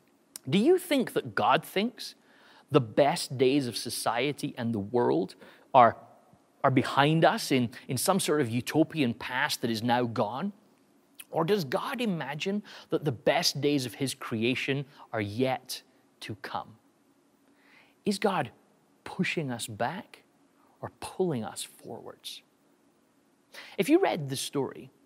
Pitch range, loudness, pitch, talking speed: 120-190 Hz, -28 LUFS, 145 Hz, 140 wpm